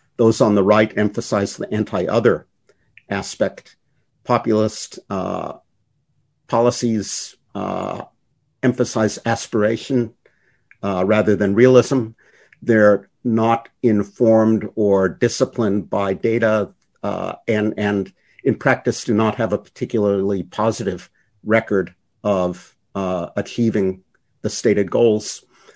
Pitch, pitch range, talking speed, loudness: 110 Hz, 105-120 Hz, 100 wpm, -19 LUFS